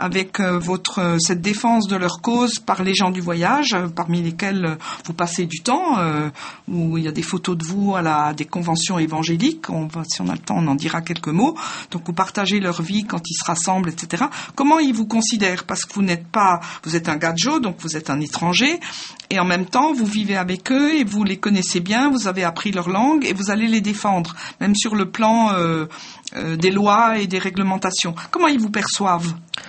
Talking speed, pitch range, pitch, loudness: 230 wpm, 170-215 Hz, 185 Hz, -19 LUFS